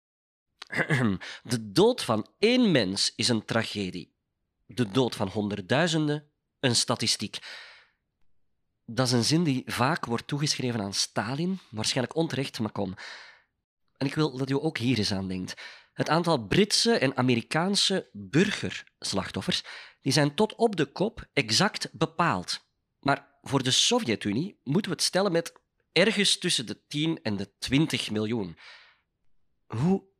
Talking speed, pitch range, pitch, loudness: 140 wpm, 110-160 Hz, 130 Hz, -27 LUFS